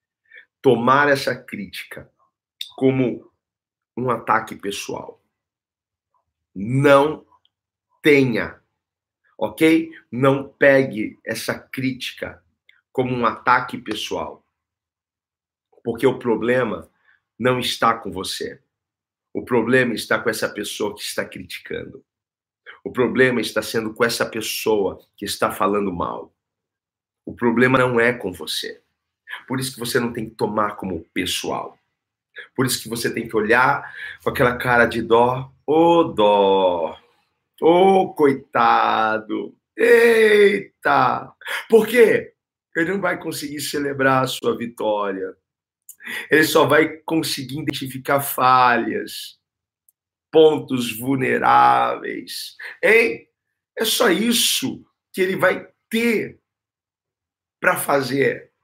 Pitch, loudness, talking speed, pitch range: 130 Hz, -19 LUFS, 110 wpm, 115-165 Hz